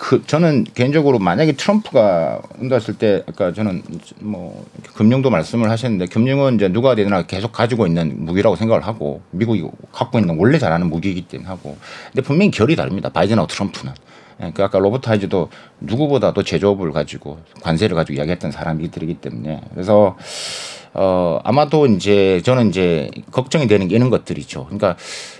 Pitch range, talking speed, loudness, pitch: 85-125 Hz, 410 characters per minute, -17 LUFS, 100 Hz